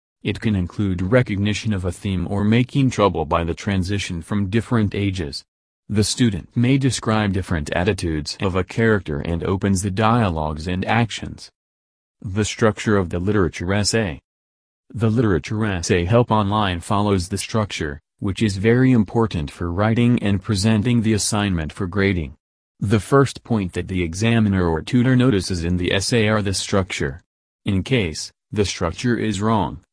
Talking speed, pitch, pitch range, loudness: 155 wpm, 100 Hz, 90-110 Hz, -20 LUFS